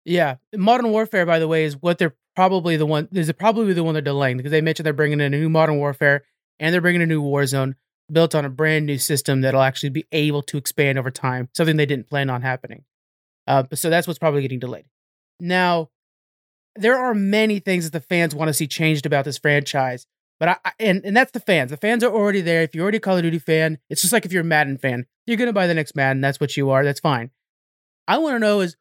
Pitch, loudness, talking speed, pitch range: 155 Hz, -20 LUFS, 255 wpm, 140-180 Hz